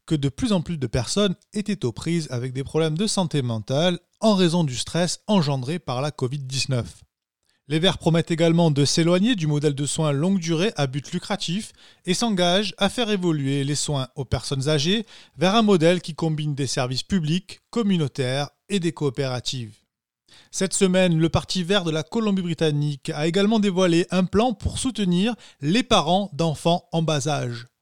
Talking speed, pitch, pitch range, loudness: 175 wpm, 165 Hz, 140-190 Hz, -23 LUFS